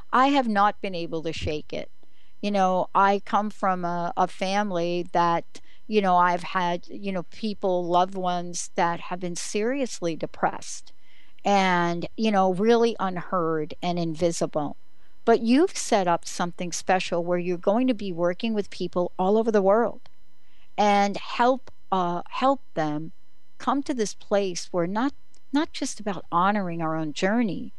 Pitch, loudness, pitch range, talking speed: 185 Hz, -25 LUFS, 175-210 Hz, 160 wpm